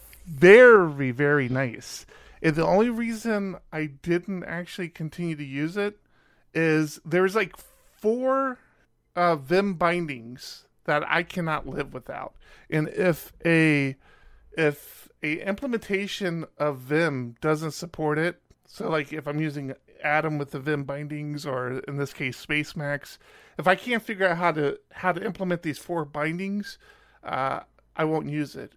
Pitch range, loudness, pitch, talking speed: 150-185 Hz, -25 LUFS, 160 Hz, 145 wpm